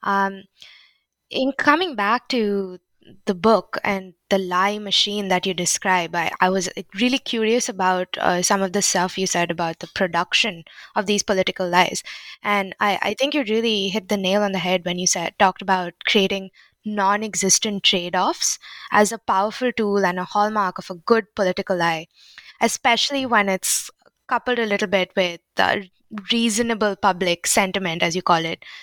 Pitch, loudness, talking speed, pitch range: 195 Hz, -20 LUFS, 170 wpm, 185-215 Hz